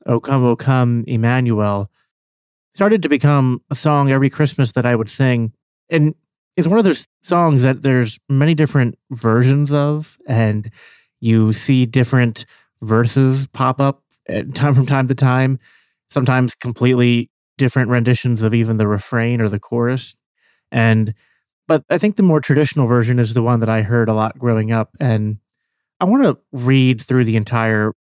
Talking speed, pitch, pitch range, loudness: 165 wpm, 125 Hz, 115-135 Hz, -16 LUFS